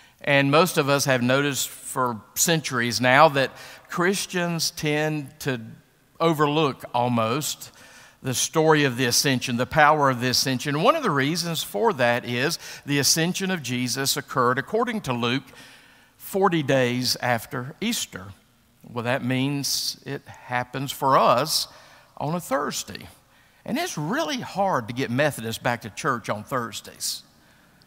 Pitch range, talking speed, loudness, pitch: 125-160 Hz, 140 wpm, -23 LUFS, 140 Hz